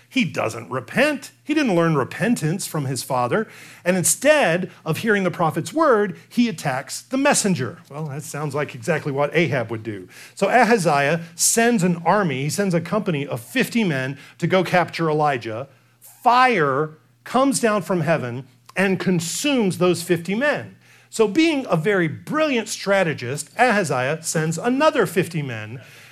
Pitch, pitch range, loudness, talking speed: 170 Hz, 145-215 Hz, -20 LUFS, 155 wpm